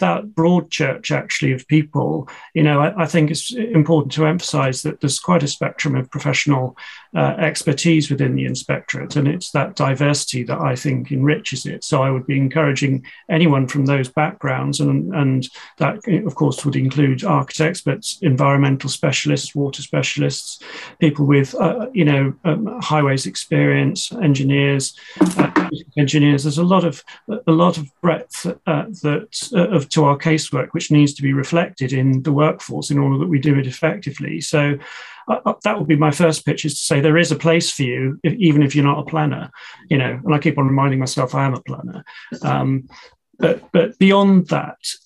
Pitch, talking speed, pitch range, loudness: 150 Hz, 190 wpm, 140-160 Hz, -18 LUFS